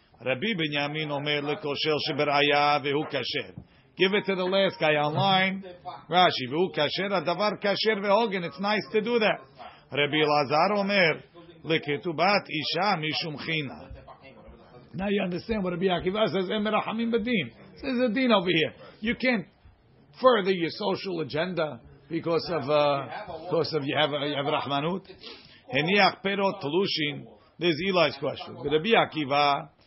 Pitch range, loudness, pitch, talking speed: 150-195 Hz, -26 LUFS, 170 Hz, 150 wpm